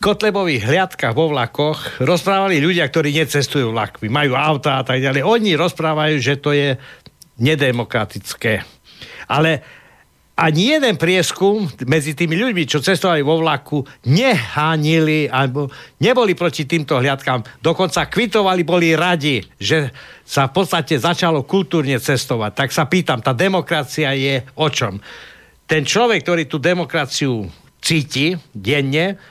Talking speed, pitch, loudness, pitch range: 130 wpm, 155 Hz, -17 LUFS, 135-175 Hz